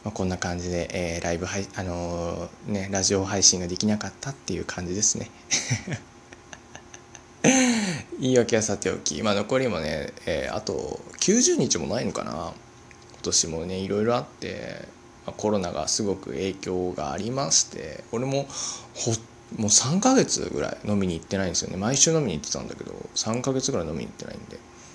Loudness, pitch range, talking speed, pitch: -25 LUFS, 90-120 Hz, 340 characters per minute, 100 Hz